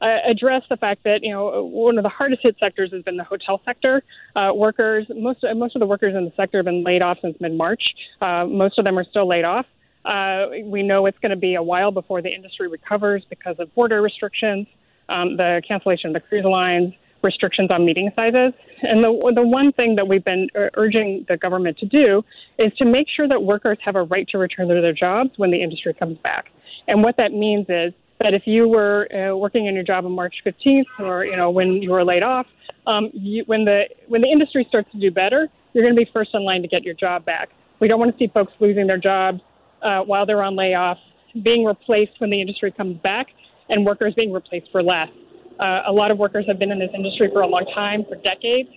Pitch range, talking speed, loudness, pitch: 185-225 Hz, 240 wpm, -19 LUFS, 200 Hz